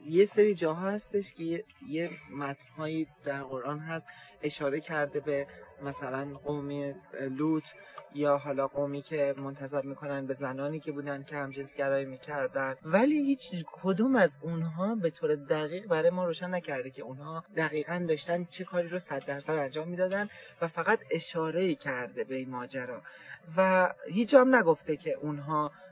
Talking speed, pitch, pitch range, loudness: 155 wpm, 155 Hz, 140-175 Hz, -31 LUFS